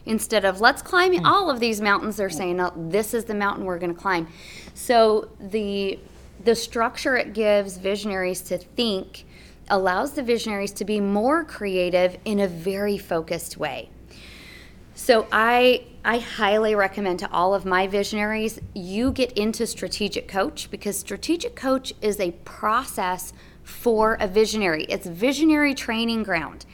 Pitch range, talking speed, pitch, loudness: 185-230 Hz, 150 wpm, 205 Hz, -23 LUFS